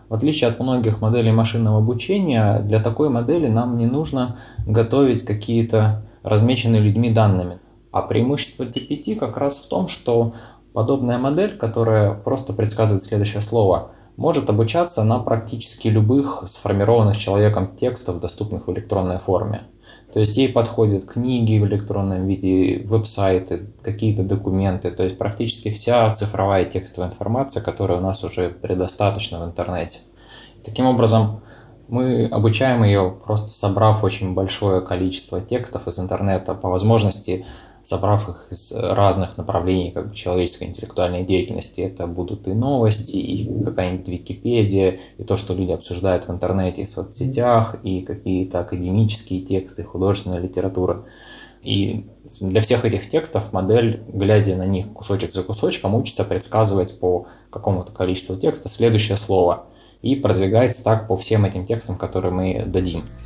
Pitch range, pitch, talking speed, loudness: 95-115 Hz, 105 Hz, 140 wpm, -20 LUFS